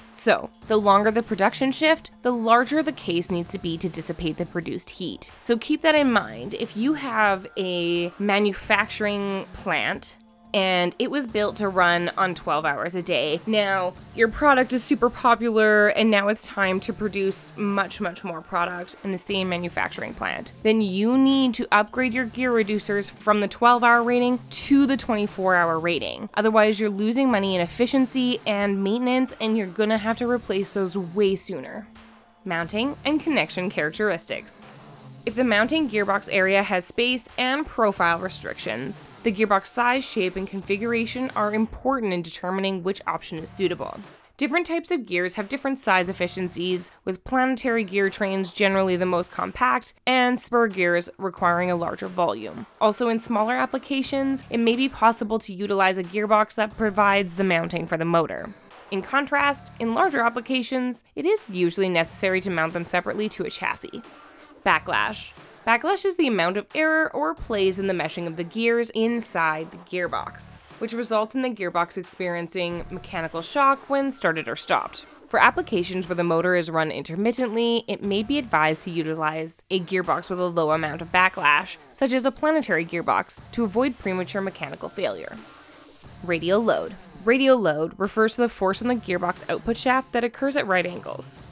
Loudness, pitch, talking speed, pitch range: -23 LUFS, 205 Hz, 170 wpm, 180-240 Hz